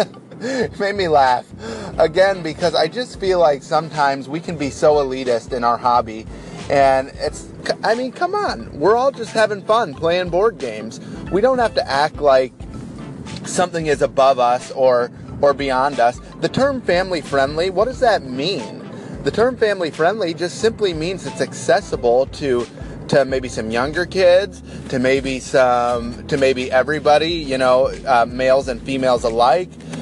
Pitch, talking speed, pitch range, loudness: 145 Hz, 165 wpm, 130-185 Hz, -18 LUFS